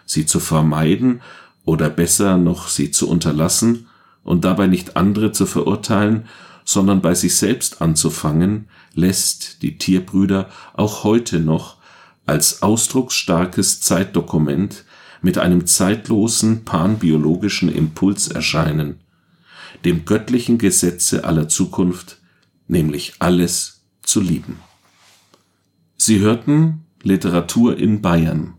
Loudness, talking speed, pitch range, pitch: -17 LUFS, 105 wpm, 85-105 Hz, 90 Hz